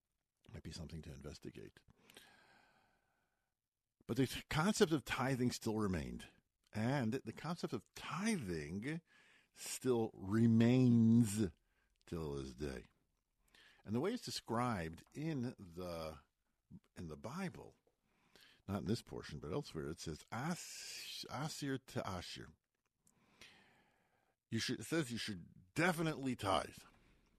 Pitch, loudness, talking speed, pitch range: 115 Hz, -40 LUFS, 110 wpm, 85-135 Hz